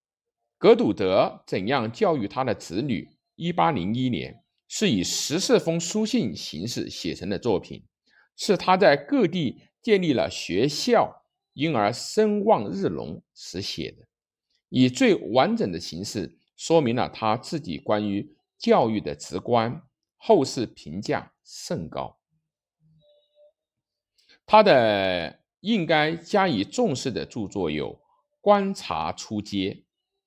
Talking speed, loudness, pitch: 180 characters per minute, -24 LUFS, 170 Hz